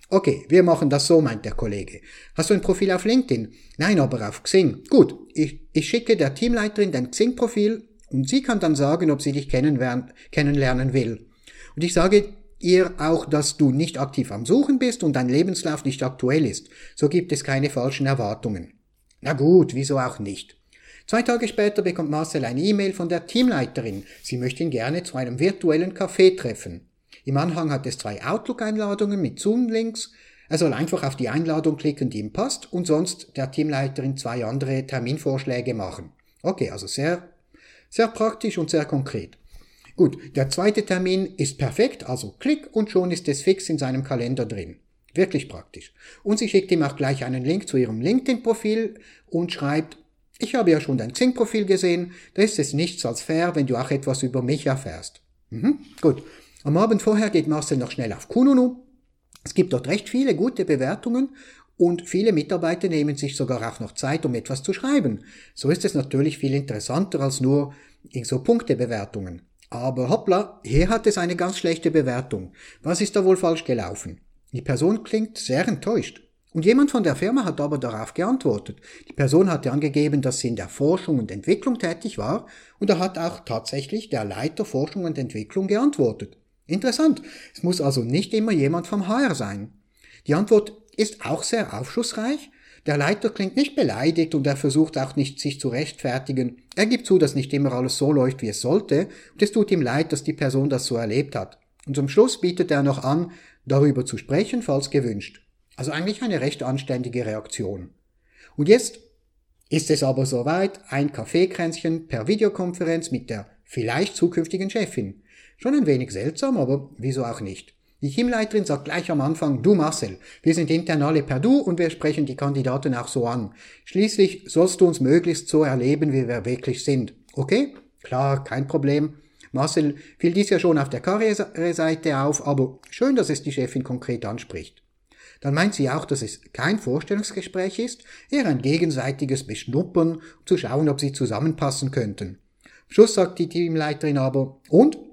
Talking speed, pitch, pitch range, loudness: 180 wpm, 155 Hz, 130-190 Hz, -23 LUFS